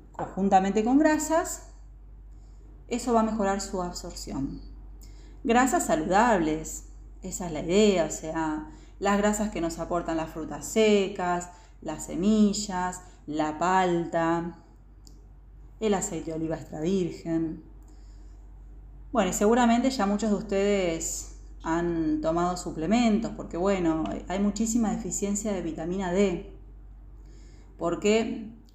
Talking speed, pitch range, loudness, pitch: 115 wpm, 165-210 Hz, -27 LUFS, 180 Hz